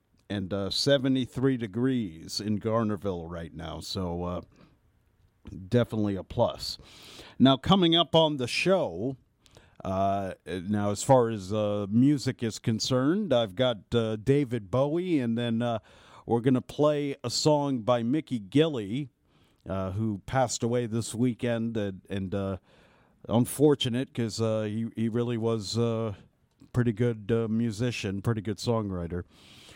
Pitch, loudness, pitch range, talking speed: 115 Hz, -28 LUFS, 100-125 Hz, 140 wpm